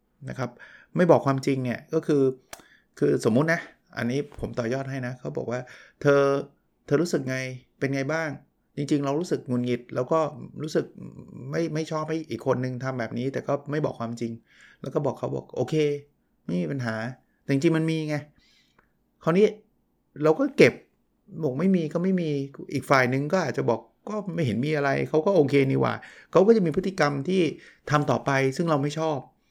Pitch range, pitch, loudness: 130-160 Hz, 145 Hz, -26 LUFS